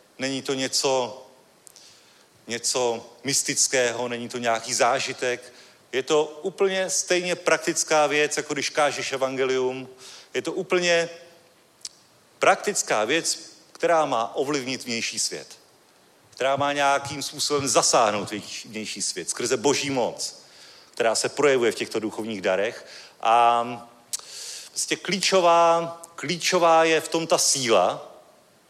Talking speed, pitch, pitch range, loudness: 115 wpm, 140 Hz, 125-170 Hz, -23 LUFS